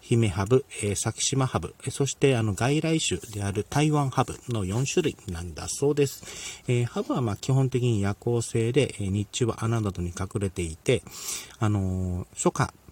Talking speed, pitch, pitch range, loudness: 285 characters per minute, 115 Hz, 100-130 Hz, -27 LUFS